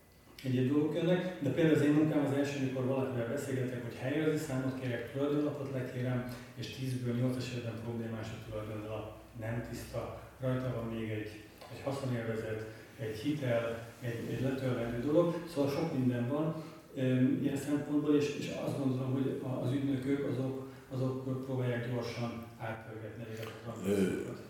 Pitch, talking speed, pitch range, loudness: 130 Hz, 140 wpm, 115-140 Hz, -35 LUFS